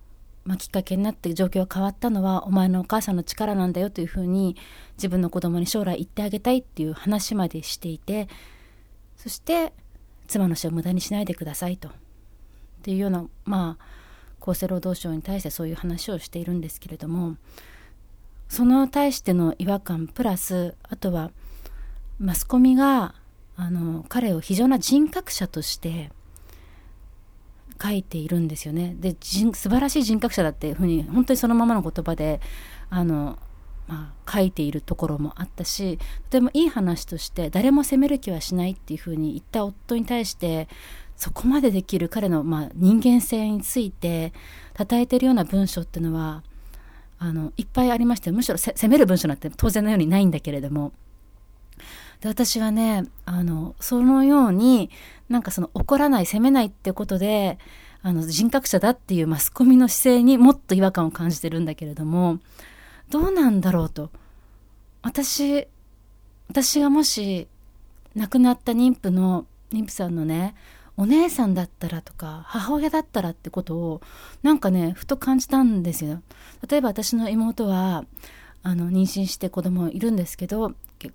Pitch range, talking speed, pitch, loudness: 160-225 Hz, 330 characters per minute, 185 Hz, -23 LUFS